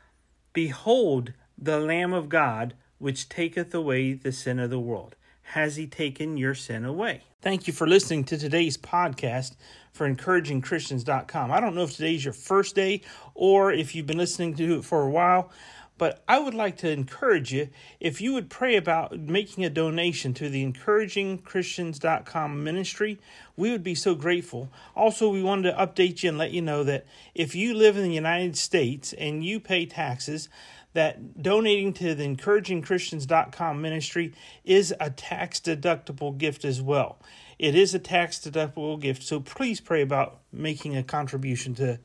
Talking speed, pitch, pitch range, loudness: 170 wpm, 160 Hz, 140-180 Hz, -26 LUFS